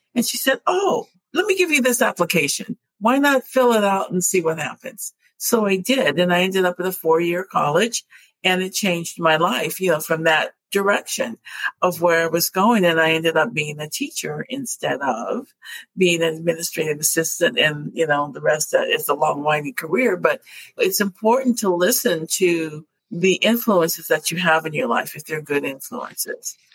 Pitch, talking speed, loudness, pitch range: 180 Hz, 195 wpm, -20 LUFS, 165-235 Hz